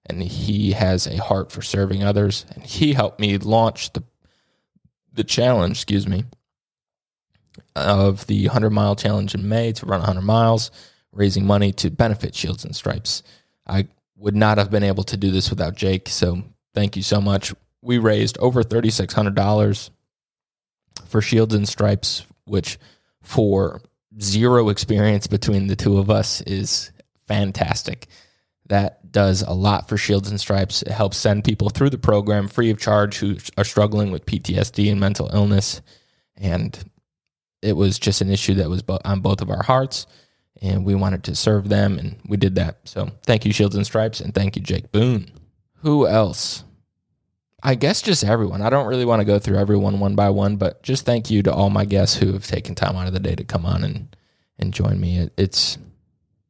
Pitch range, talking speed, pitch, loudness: 95-110 Hz, 185 wpm, 100 Hz, -20 LUFS